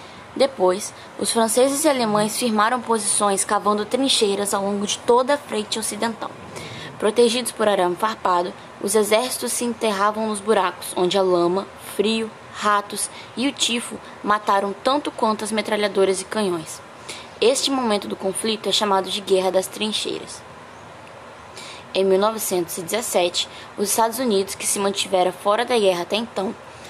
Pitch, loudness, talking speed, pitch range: 210 Hz, -21 LUFS, 145 wpm, 195-230 Hz